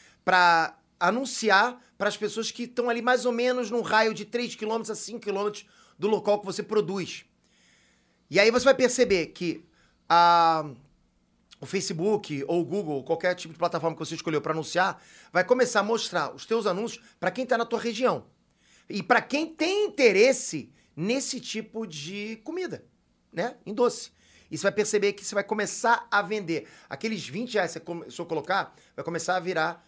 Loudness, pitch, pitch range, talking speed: -26 LUFS, 205 Hz, 170-235 Hz, 185 wpm